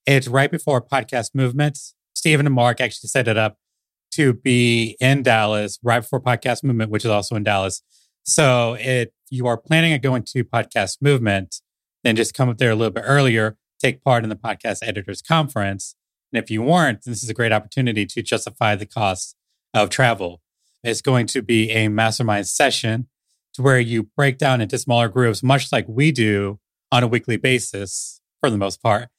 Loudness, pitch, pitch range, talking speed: -19 LUFS, 120 Hz, 110-130 Hz, 190 wpm